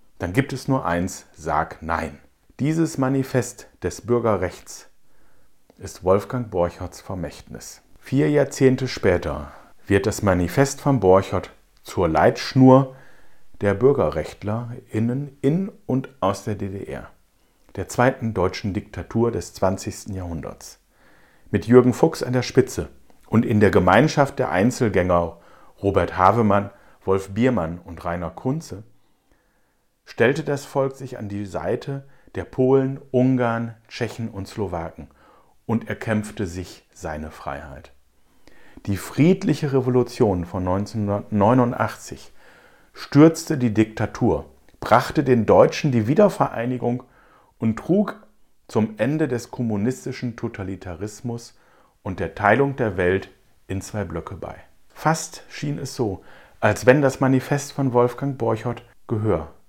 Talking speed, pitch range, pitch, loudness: 120 wpm, 95-130 Hz, 115 Hz, -22 LUFS